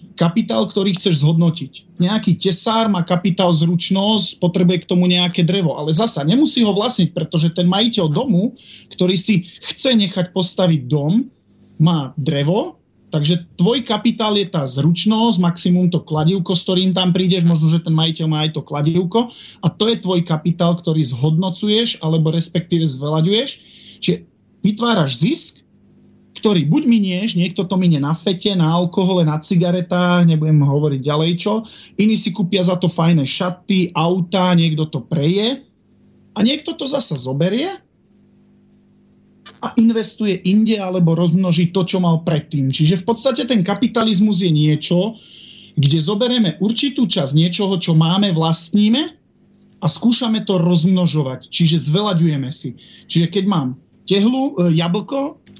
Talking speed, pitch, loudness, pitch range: 145 wpm, 180 Hz, -16 LUFS, 165-210 Hz